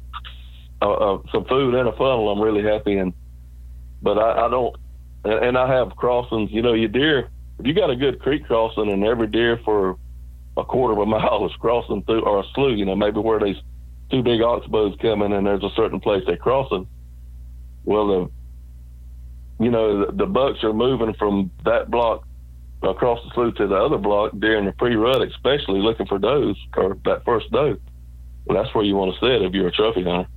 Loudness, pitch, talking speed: -20 LUFS, 95 Hz, 205 wpm